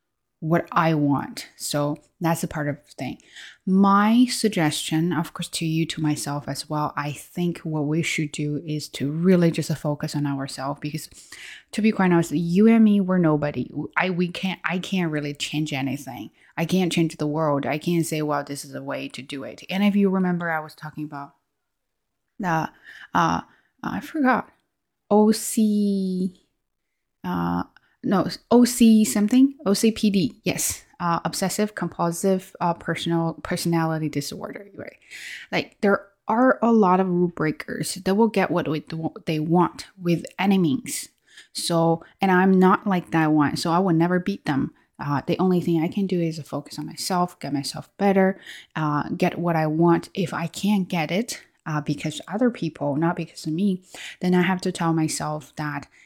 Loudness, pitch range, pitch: -23 LUFS, 150-190 Hz, 170 Hz